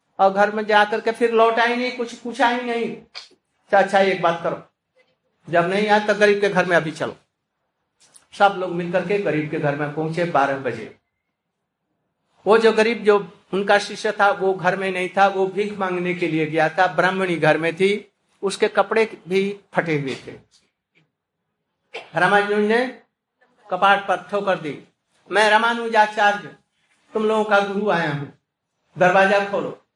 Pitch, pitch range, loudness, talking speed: 200 Hz, 180-215 Hz, -20 LUFS, 165 wpm